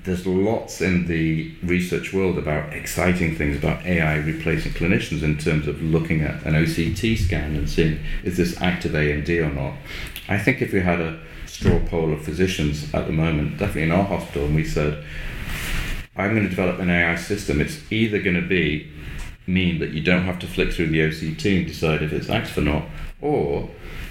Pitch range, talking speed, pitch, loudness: 75-90 Hz, 195 wpm, 80 Hz, -22 LUFS